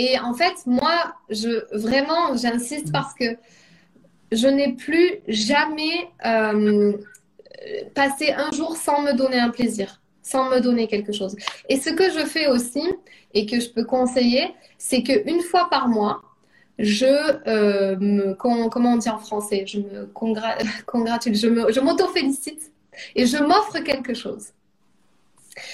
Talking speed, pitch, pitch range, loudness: 150 wpm, 250 Hz, 220-300 Hz, -21 LUFS